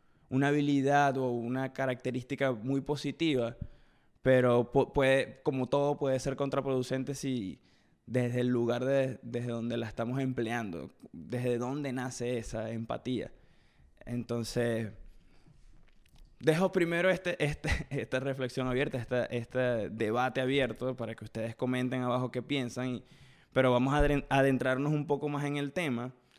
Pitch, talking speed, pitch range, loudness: 130 Hz, 135 wpm, 120-140 Hz, -32 LUFS